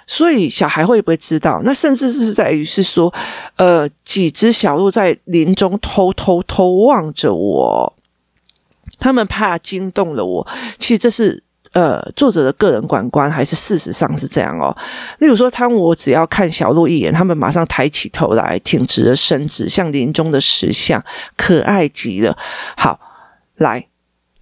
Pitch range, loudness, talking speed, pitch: 160-225 Hz, -13 LUFS, 235 characters per minute, 185 Hz